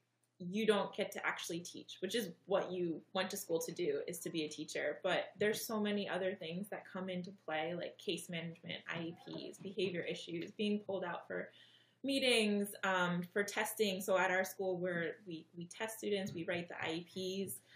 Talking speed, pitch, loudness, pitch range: 195 wpm, 185 Hz, -39 LUFS, 170-200 Hz